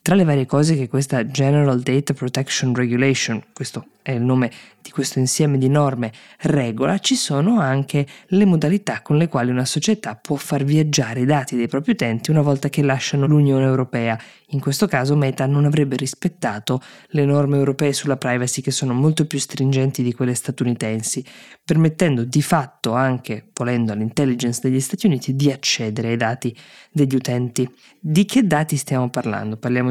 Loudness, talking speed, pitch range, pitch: -19 LUFS, 170 wpm, 125-150 Hz, 135 Hz